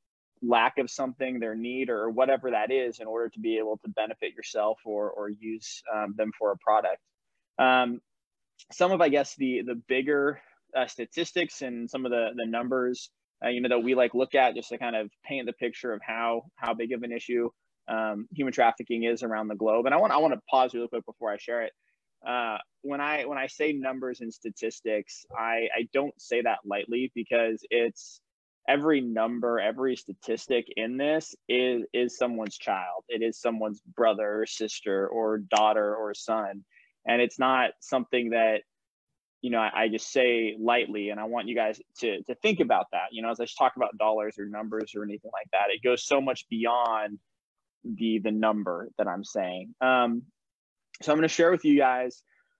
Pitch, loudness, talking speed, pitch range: 115 Hz, -28 LUFS, 200 wpm, 110-130 Hz